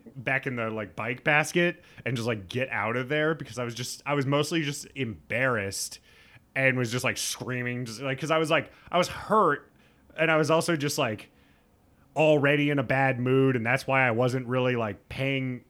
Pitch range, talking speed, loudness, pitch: 120-145 Hz, 210 wpm, -27 LUFS, 130 Hz